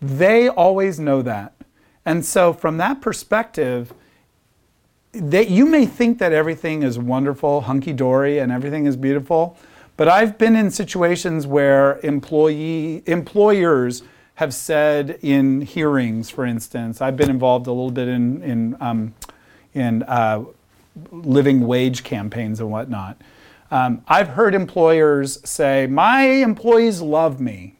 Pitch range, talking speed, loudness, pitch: 125-170 Hz, 130 wpm, -18 LUFS, 140 Hz